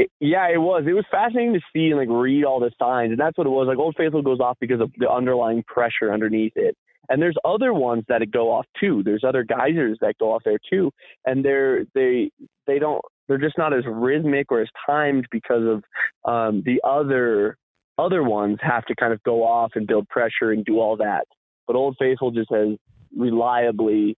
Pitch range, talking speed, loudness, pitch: 115-155 Hz, 215 wpm, -21 LUFS, 125 Hz